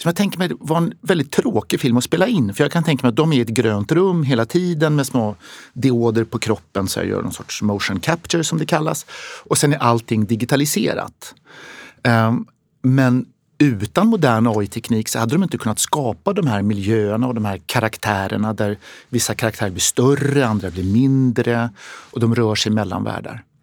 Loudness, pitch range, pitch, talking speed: -18 LUFS, 110-150 Hz, 120 Hz, 200 wpm